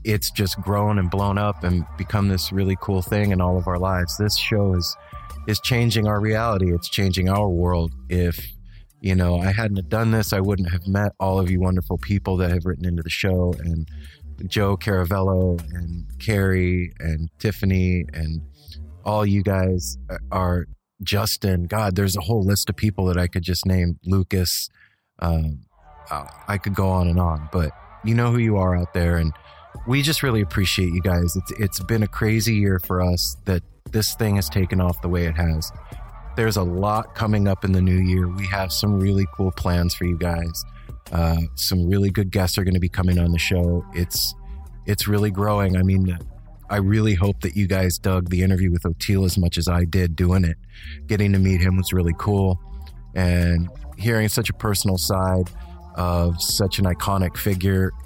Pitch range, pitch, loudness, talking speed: 85-100 Hz, 95 Hz, -22 LUFS, 195 wpm